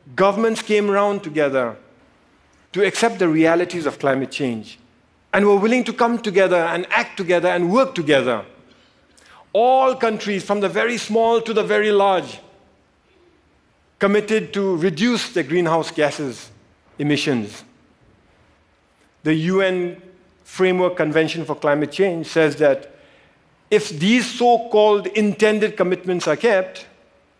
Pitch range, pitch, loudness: 155-210 Hz, 185 Hz, -19 LUFS